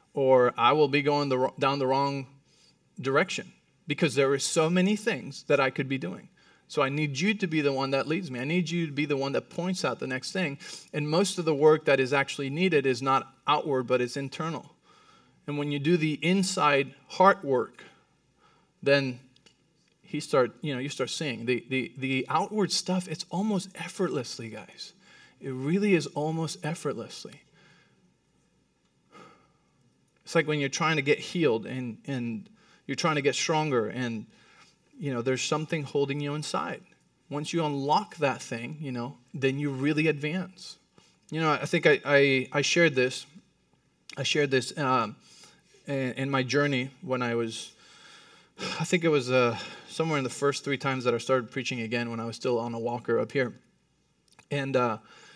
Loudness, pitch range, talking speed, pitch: -28 LUFS, 130-160 Hz, 185 wpm, 145 Hz